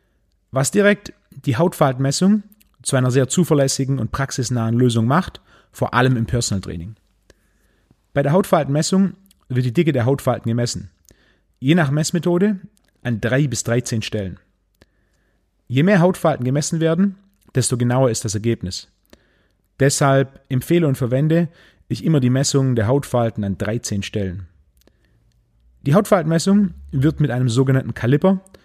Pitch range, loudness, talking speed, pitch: 115-160 Hz, -19 LUFS, 135 wpm, 130 Hz